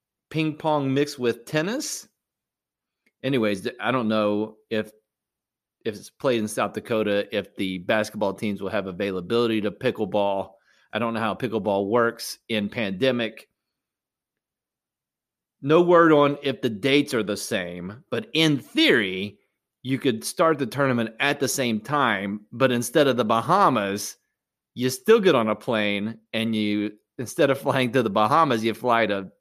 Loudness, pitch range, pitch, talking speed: -23 LUFS, 105-135 Hz, 115 Hz, 155 wpm